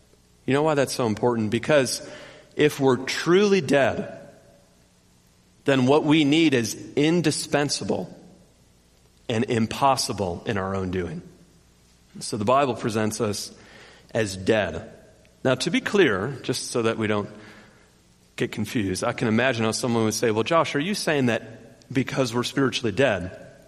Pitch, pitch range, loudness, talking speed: 115 Hz, 105-140 Hz, -23 LUFS, 145 wpm